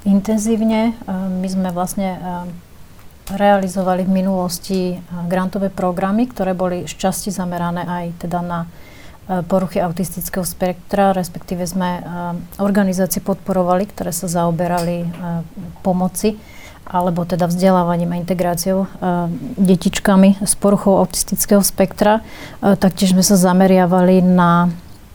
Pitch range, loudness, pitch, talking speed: 175-195 Hz, -17 LUFS, 185 Hz, 105 wpm